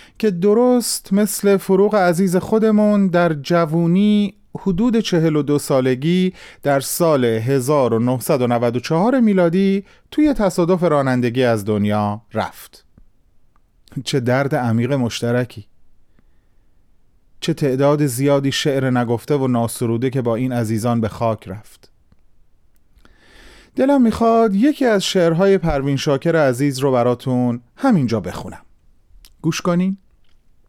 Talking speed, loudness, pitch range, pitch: 105 wpm, -17 LUFS, 120-190 Hz, 140 Hz